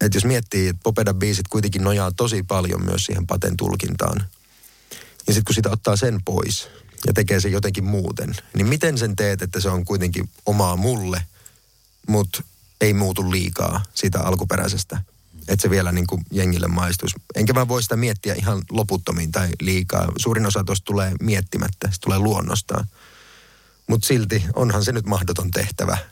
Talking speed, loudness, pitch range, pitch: 165 wpm, -21 LUFS, 95-105 Hz, 100 Hz